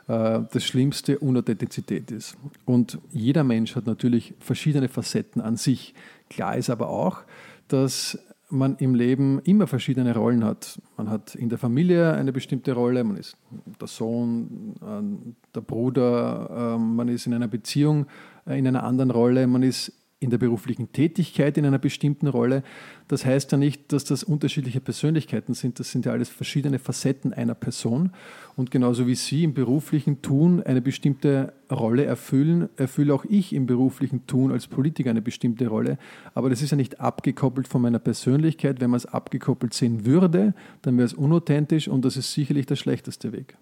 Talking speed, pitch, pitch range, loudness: 170 wpm, 130 Hz, 120-145 Hz, -24 LUFS